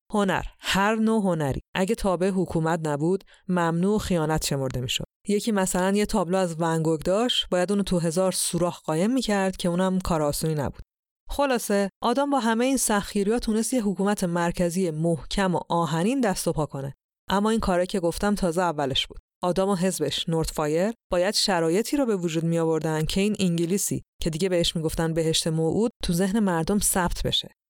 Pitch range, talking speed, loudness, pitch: 165-205 Hz, 180 wpm, -25 LUFS, 180 Hz